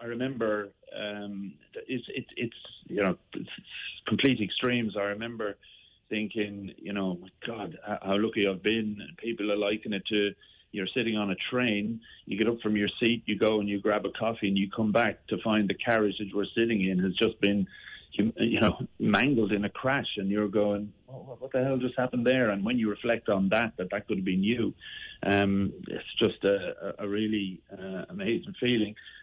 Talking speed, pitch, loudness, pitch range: 200 wpm, 105 Hz, -29 LUFS, 100-115 Hz